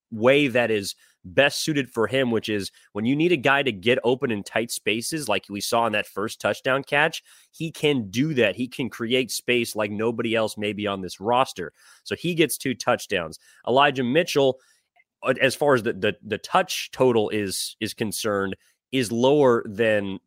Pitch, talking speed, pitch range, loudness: 120 Hz, 190 wpm, 105-135 Hz, -23 LUFS